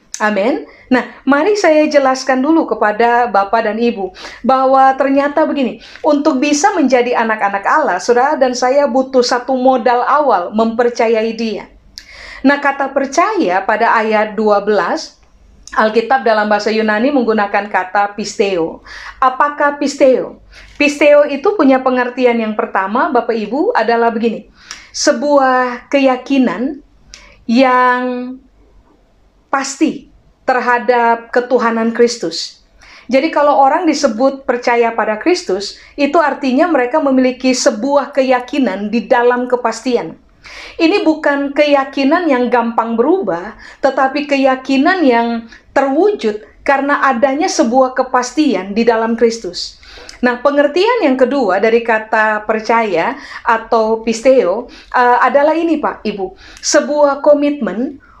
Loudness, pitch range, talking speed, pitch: -13 LUFS, 230-285 Hz, 110 wpm, 255 Hz